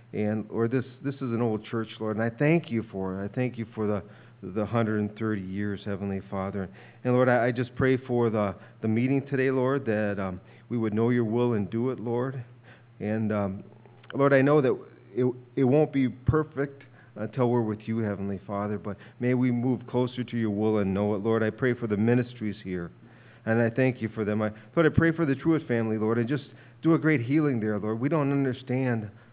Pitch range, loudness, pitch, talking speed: 105-125 Hz, -27 LUFS, 115 Hz, 225 wpm